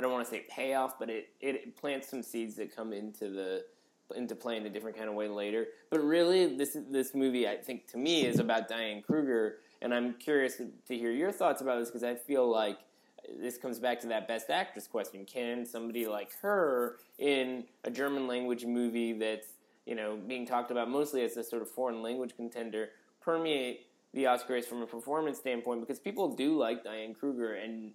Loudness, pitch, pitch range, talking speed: -34 LUFS, 120 Hz, 115-130 Hz, 205 wpm